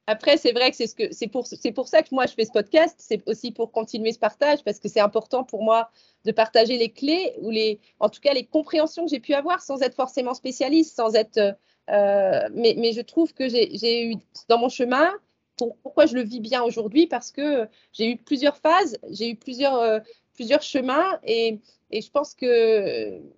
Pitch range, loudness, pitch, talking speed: 225-290 Hz, -23 LUFS, 250 Hz, 225 wpm